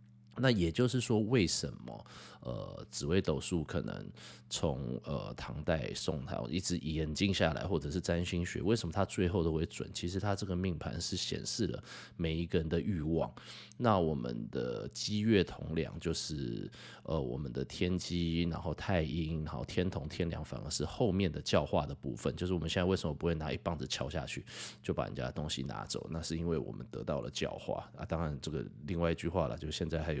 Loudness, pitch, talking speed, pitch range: -36 LUFS, 85 Hz, 300 characters per minute, 80-95 Hz